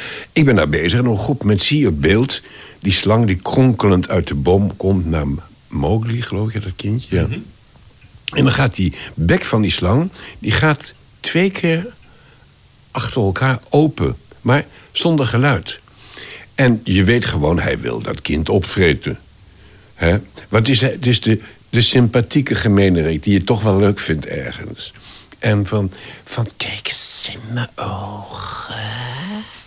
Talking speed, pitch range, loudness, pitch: 155 wpm, 95-125 Hz, -16 LUFS, 110 Hz